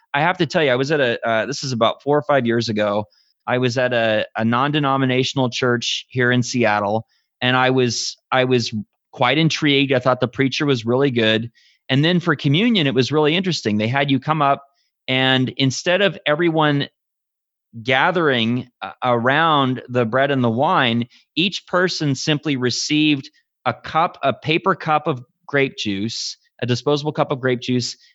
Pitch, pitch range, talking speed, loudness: 130 Hz, 120-150 Hz, 180 wpm, -19 LUFS